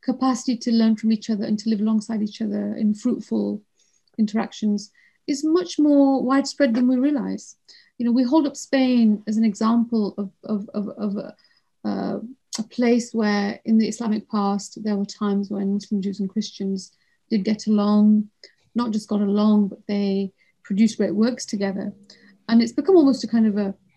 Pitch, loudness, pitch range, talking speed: 215 Hz, -22 LUFS, 205-240 Hz, 185 wpm